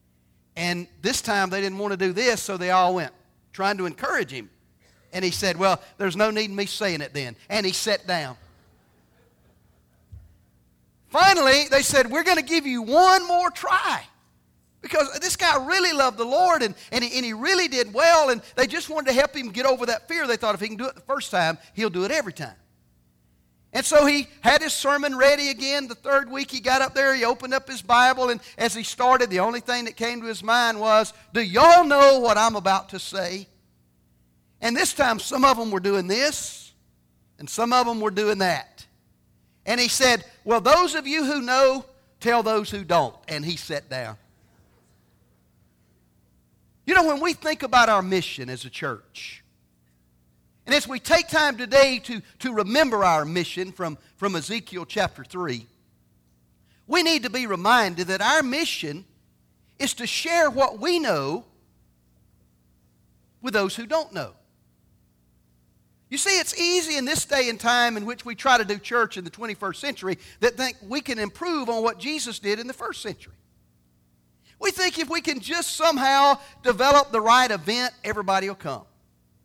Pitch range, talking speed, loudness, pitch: 165-275 Hz, 190 wpm, -22 LUFS, 225 Hz